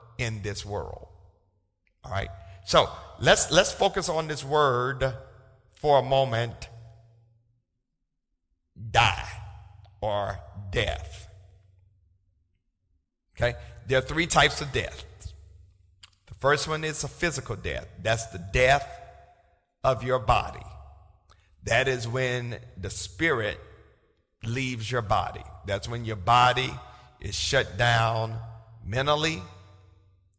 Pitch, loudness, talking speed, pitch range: 110 Hz, -26 LUFS, 105 wpm, 95-125 Hz